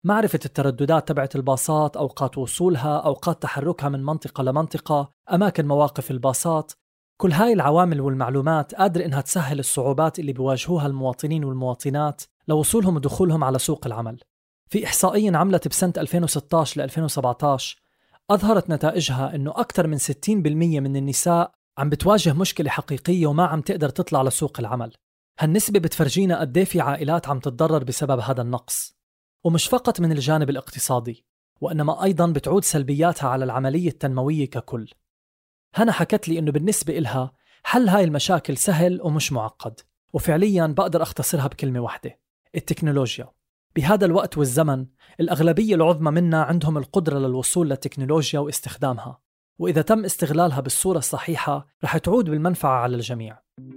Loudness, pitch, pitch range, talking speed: -22 LUFS, 155 Hz, 135-175 Hz, 135 wpm